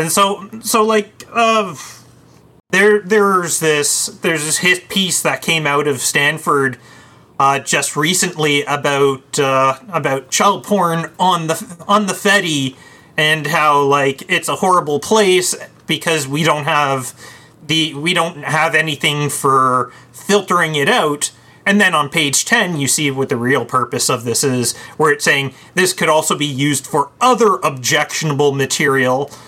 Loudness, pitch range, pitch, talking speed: -15 LUFS, 140-180 Hz, 155 Hz, 155 wpm